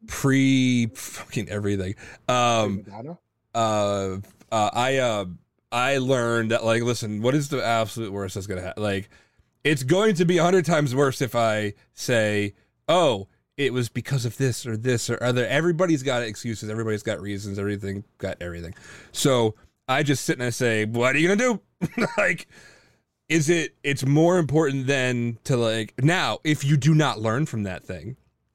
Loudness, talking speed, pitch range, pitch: -23 LUFS, 170 wpm, 105-140 Hz, 120 Hz